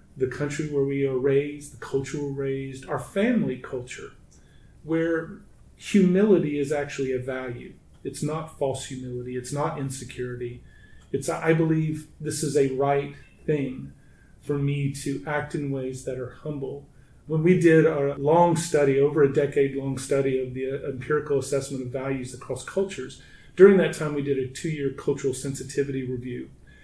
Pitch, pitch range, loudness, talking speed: 140 Hz, 130-155 Hz, -25 LUFS, 165 wpm